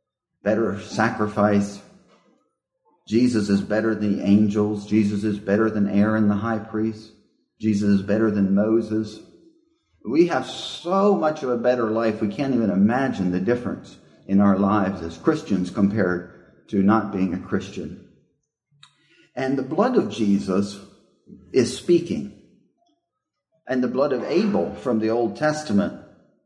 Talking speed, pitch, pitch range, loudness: 140 wpm, 110 Hz, 100-125 Hz, -22 LUFS